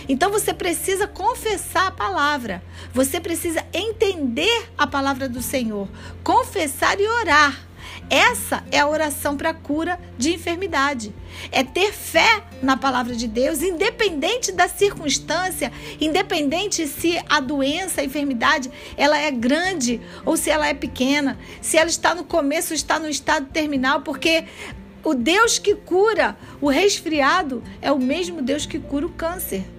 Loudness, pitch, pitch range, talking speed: -20 LUFS, 315 Hz, 280-360 Hz, 145 wpm